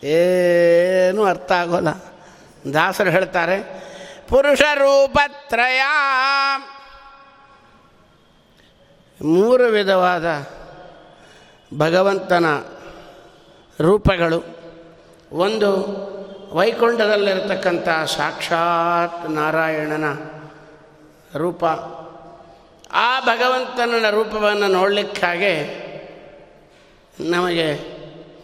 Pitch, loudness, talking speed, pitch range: 185 Hz, -18 LUFS, 45 wpm, 165-225 Hz